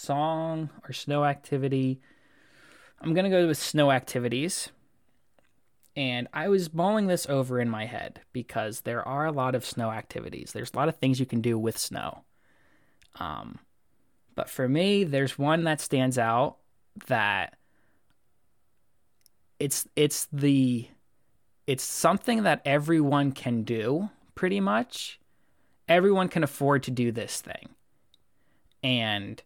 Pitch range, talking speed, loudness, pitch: 125-160 Hz, 135 wpm, -27 LUFS, 140 Hz